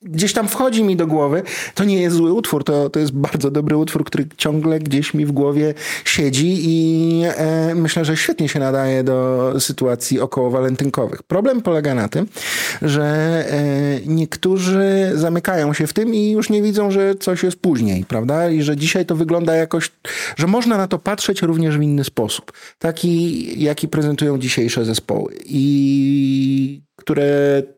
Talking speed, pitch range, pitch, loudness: 165 wpm, 140-170 Hz, 155 Hz, -17 LUFS